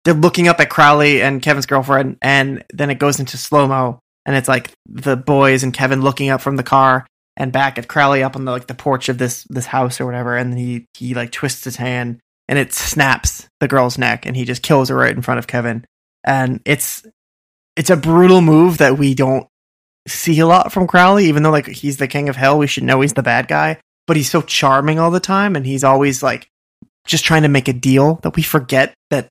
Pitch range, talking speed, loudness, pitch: 130-150 Hz, 235 wpm, -14 LUFS, 135 Hz